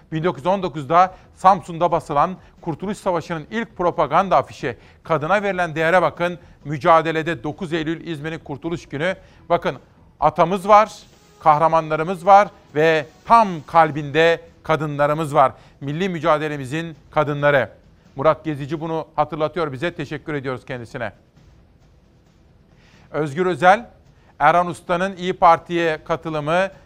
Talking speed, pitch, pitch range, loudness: 105 wpm, 165 Hz, 155-175 Hz, -19 LUFS